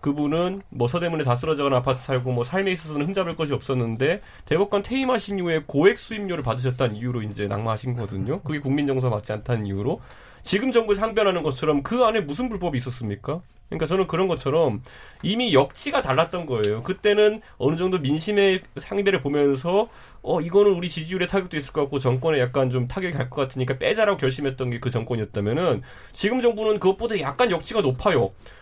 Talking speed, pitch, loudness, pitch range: 445 characters per minute, 150 Hz, -23 LUFS, 125-190 Hz